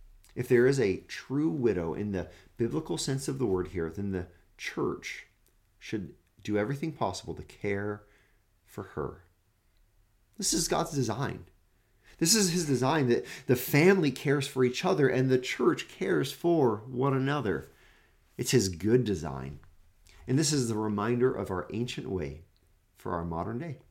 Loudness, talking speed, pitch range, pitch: -29 LUFS, 160 wpm, 95-135 Hz, 110 Hz